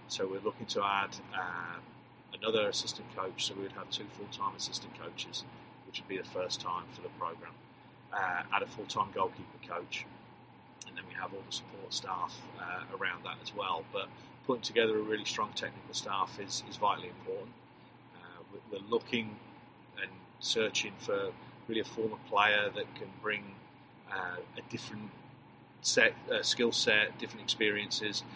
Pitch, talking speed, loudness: 115 Hz, 165 wpm, -35 LUFS